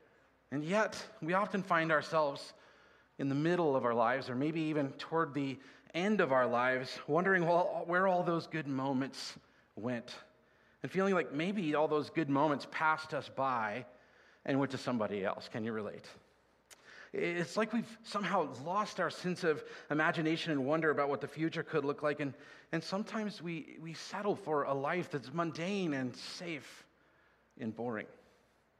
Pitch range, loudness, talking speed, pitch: 140-175 Hz, -35 LUFS, 165 wpm, 155 Hz